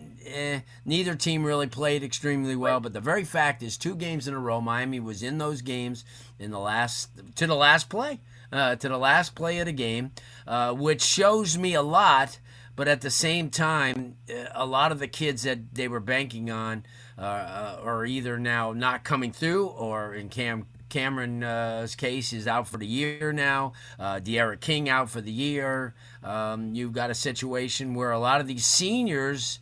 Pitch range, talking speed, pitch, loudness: 120-145 Hz, 190 wpm, 125 Hz, -26 LUFS